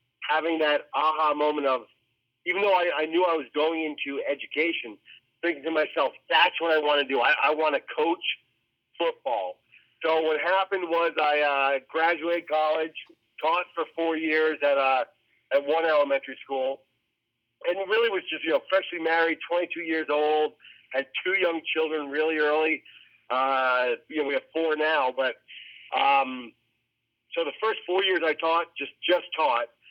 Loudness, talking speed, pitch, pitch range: -26 LUFS, 170 wpm, 155 Hz, 140-170 Hz